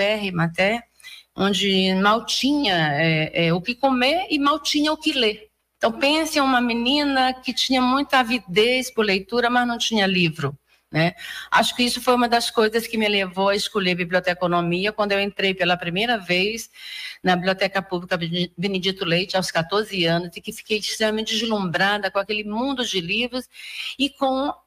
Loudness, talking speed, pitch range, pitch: -21 LUFS, 175 wpm, 190-250 Hz, 215 Hz